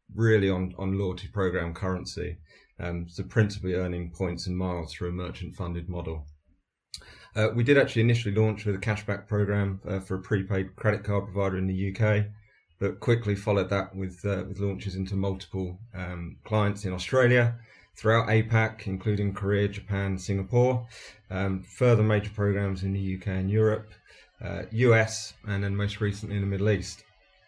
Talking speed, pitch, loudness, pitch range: 170 wpm, 100 Hz, -28 LUFS, 95-105 Hz